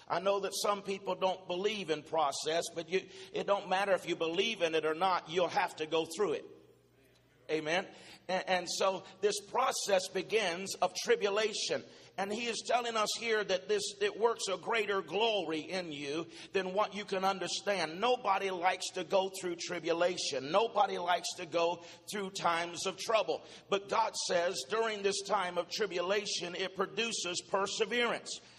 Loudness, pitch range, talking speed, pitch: -34 LUFS, 175-205 Hz, 170 wpm, 190 Hz